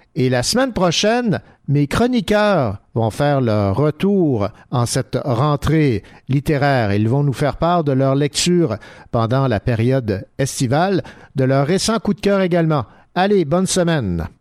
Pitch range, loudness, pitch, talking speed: 125-175 Hz, -17 LUFS, 140 Hz, 150 wpm